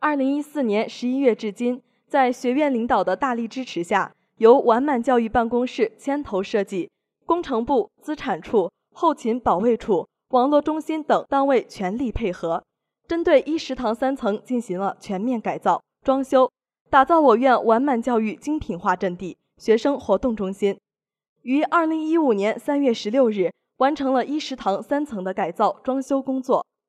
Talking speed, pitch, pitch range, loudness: 260 characters per minute, 250 Hz, 215-275 Hz, -22 LUFS